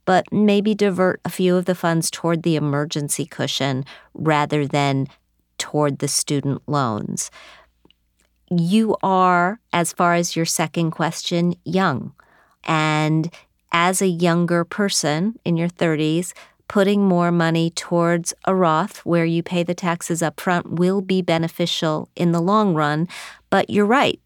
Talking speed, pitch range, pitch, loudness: 145 wpm, 155-185 Hz, 170 Hz, -20 LUFS